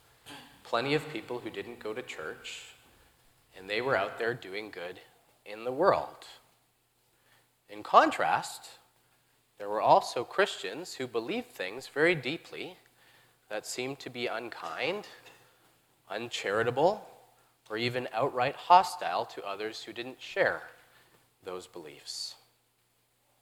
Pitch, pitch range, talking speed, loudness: 120 Hz, 105-140 Hz, 120 wpm, -31 LUFS